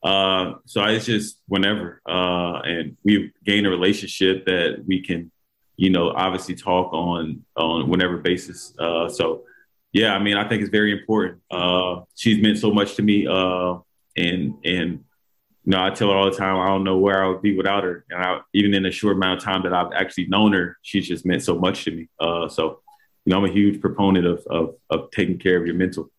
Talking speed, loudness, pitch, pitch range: 220 wpm, -21 LUFS, 95 Hz, 90-100 Hz